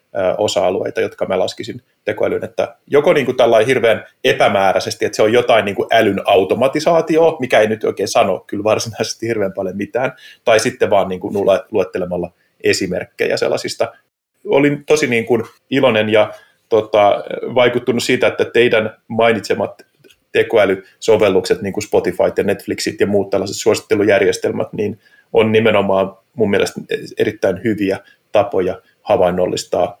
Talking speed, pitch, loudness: 135 wpm, 145 Hz, -16 LUFS